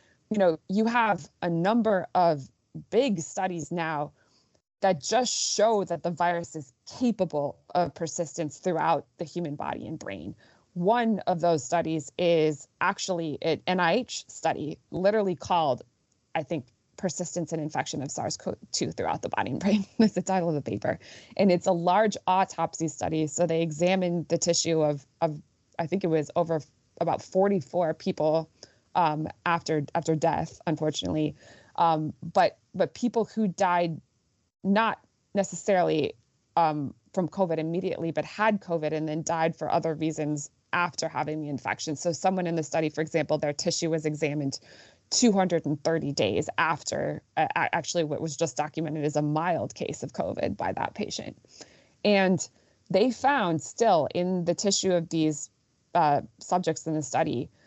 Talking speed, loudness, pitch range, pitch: 155 wpm, -27 LUFS, 155-185 Hz, 165 Hz